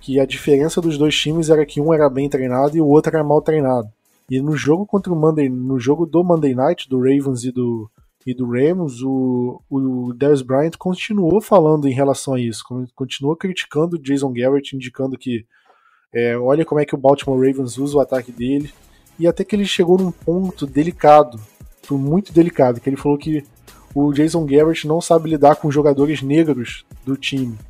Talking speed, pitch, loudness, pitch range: 195 wpm, 140 Hz, -17 LUFS, 130-155 Hz